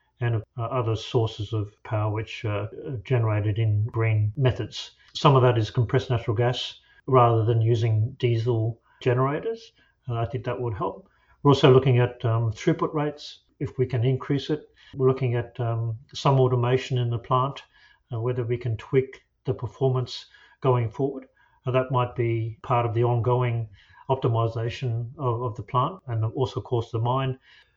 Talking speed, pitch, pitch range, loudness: 175 wpm, 125 Hz, 115-130 Hz, -25 LUFS